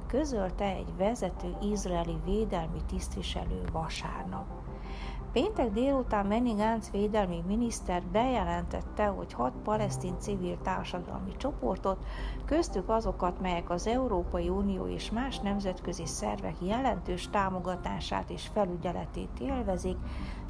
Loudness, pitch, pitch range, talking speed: -33 LUFS, 190 Hz, 170-215 Hz, 100 wpm